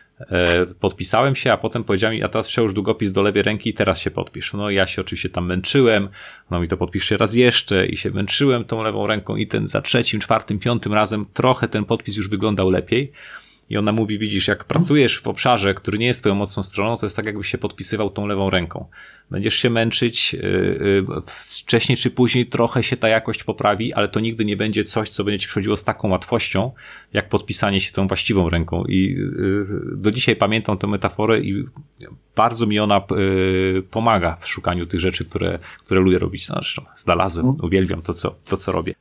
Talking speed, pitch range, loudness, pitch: 195 wpm, 95-115 Hz, -20 LUFS, 105 Hz